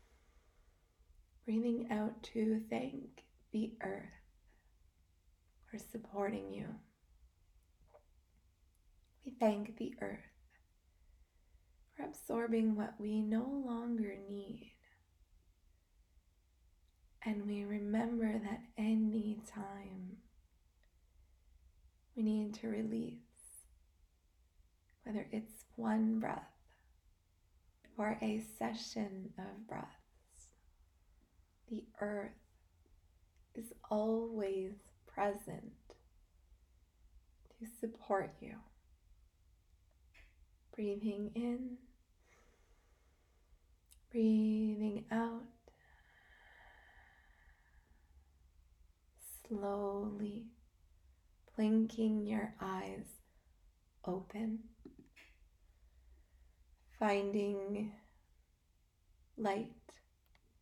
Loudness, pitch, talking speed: -40 LUFS, 85 Hz, 55 wpm